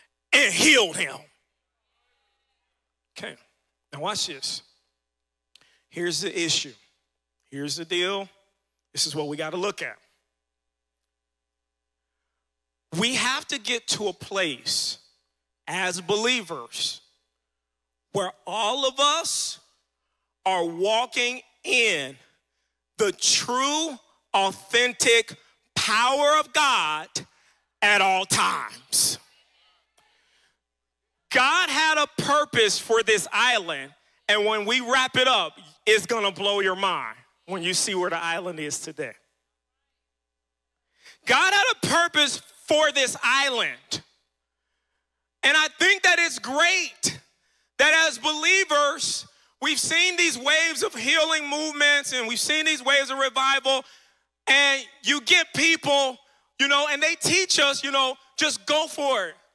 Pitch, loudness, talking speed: 220 Hz, -22 LUFS, 120 wpm